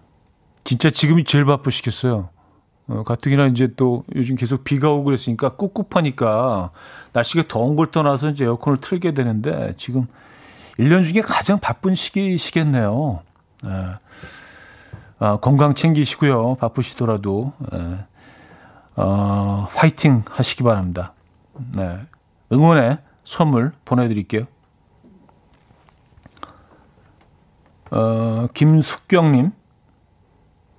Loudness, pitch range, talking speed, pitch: -19 LUFS, 105-145 Hz, 230 characters per minute, 125 Hz